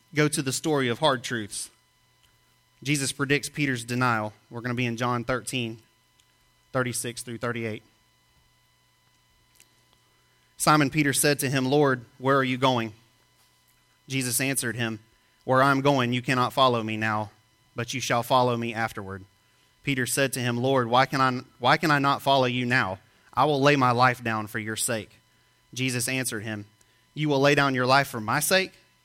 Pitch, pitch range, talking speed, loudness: 125 Hz, 115-135 Hz, 175 wpm, -25 LUFS